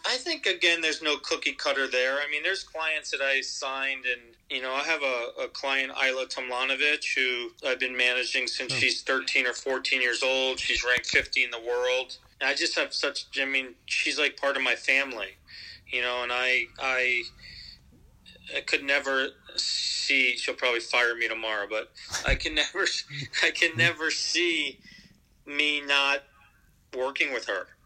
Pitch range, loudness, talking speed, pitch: 125-150 Hz, -26 LUFS, 175 wpm, 135 Hz